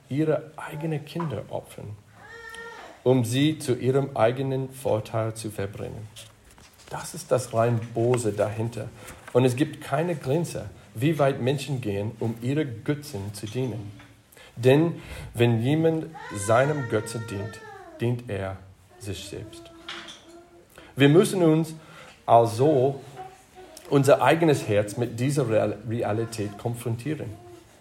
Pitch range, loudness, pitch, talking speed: 110-150 Hz, -25 LUFS, 125 Hz, 115 wpm